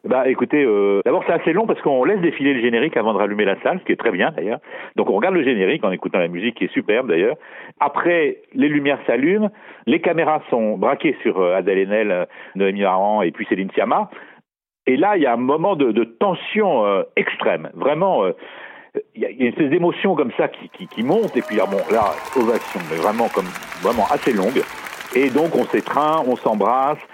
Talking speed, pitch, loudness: 215 wpm, 135 Hz, -19 LUFS